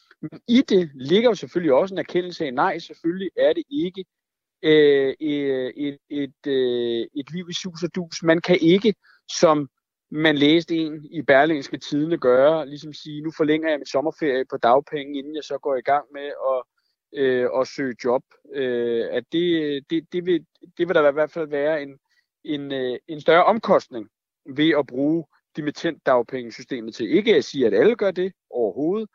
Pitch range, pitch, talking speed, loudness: 140-170 Hz, 155 Hz, 185 wpm, -22 LUFS